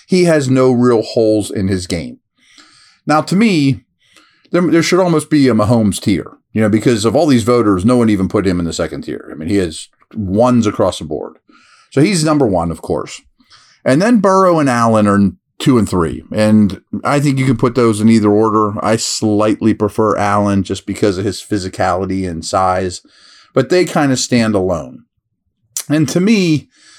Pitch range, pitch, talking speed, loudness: 100-145 Hz, 110 Hz, 195 wpm, -14 LUFS